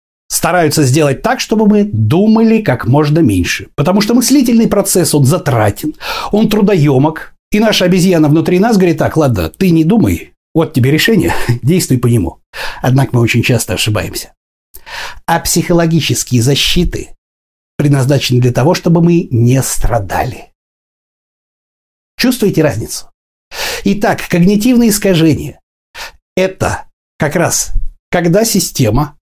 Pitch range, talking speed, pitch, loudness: 130-195 Hz, 120 wpm, 160 Hz, -11 LUFS